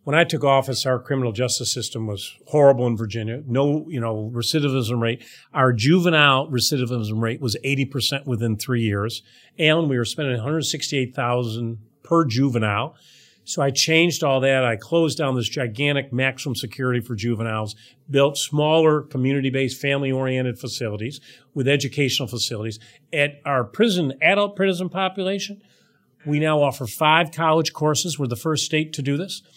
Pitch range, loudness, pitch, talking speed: 120-150 Hz, -21 LUFS, 135 Hz, 150 wpm